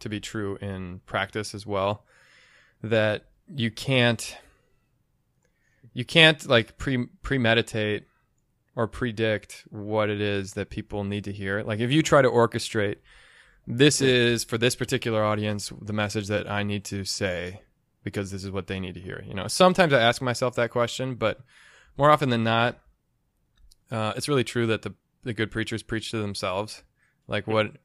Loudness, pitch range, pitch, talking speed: -25 LUFS, 105-120 Hz, 110 Hz, 170 wpm